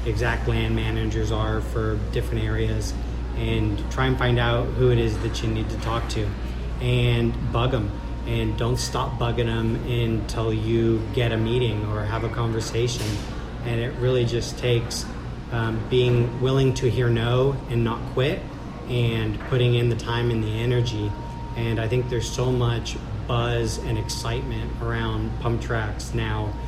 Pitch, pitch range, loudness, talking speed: 115 Hz, 110-120 Hz, -24 LUFS, 165 wpm